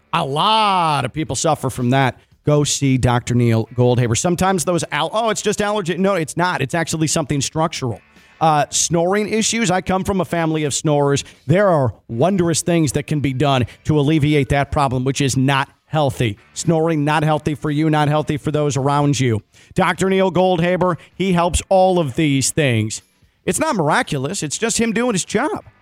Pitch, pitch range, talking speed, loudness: 150 Hz, 135-180 Hz, 190 wpm, -18 LUFS